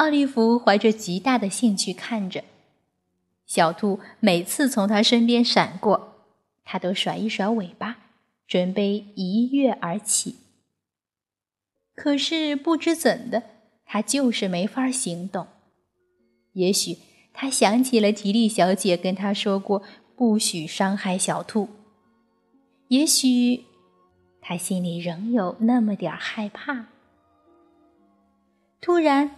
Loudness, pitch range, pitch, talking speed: -23 LUFS, 185-245 Hz, 210 Hz, 165 characters per minute